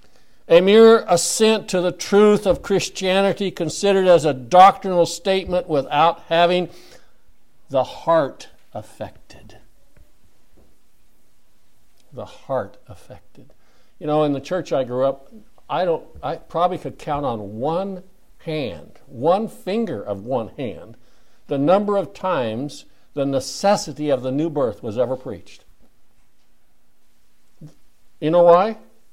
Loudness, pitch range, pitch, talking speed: -19 LUFS, 160-200 Hz, 180 Hz, 120 wpm